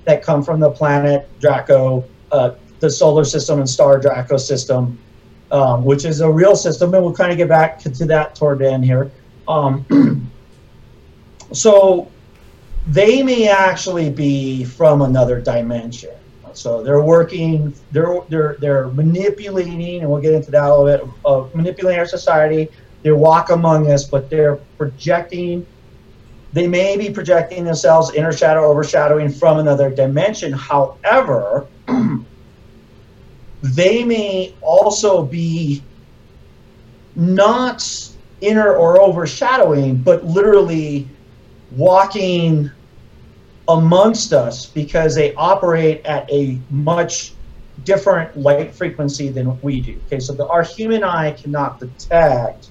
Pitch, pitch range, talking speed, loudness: 155 Hz, 140-175 Hz, 130 wpm, -15 LUFS